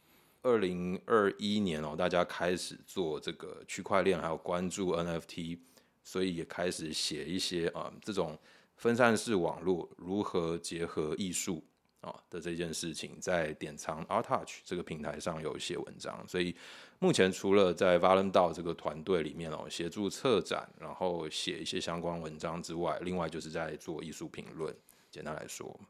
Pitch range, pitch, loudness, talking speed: 80-95 Hz, 85 Hz, -34 LUFS, 285 characters per minute